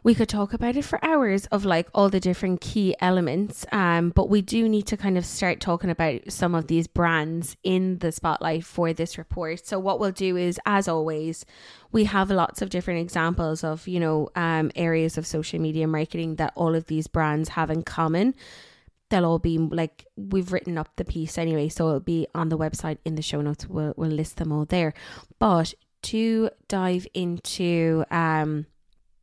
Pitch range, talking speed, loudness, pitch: 160-190 Hz, 195 wpm, -25 LUFS, 170 Hz